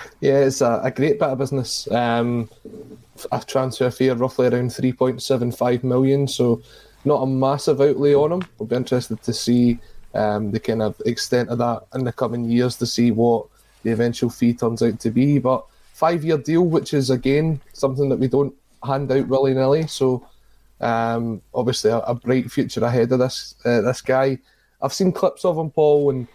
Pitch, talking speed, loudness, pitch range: 130 Hz, 180 wpm, -20 LUFS, 120-135 Hz